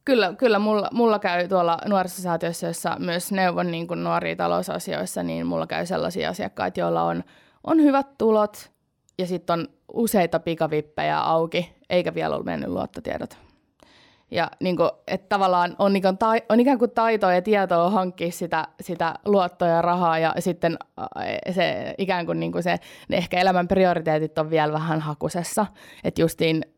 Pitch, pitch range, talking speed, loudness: 175 Hz, 160-195 Hz, 160 wpm, -23 LUFS